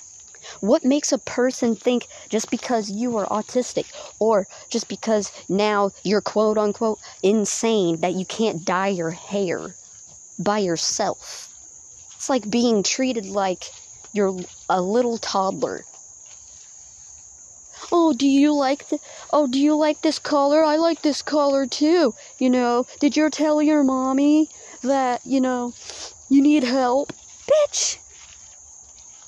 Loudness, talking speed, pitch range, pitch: -21 LUFS, 135 wpm, 210-290 Hz, 245 Hz